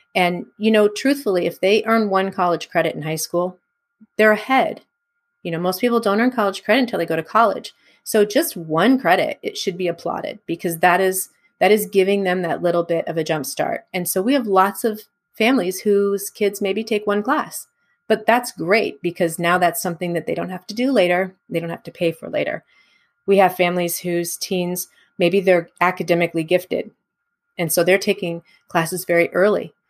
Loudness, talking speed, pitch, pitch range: -19 LUFS, 200 wpm, 190 Hz, 175-215 Hz